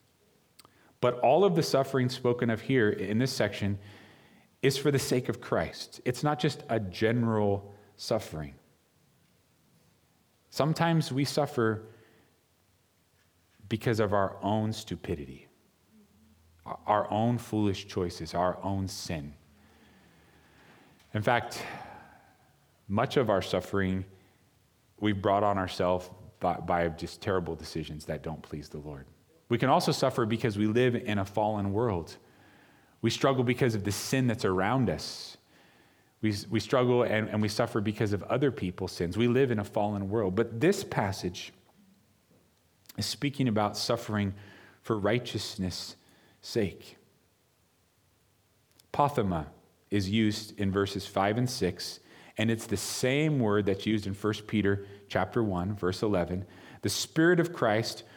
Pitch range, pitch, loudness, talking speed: 95-120 Hz, 105 Hz, -30 LUFS, 135 wpm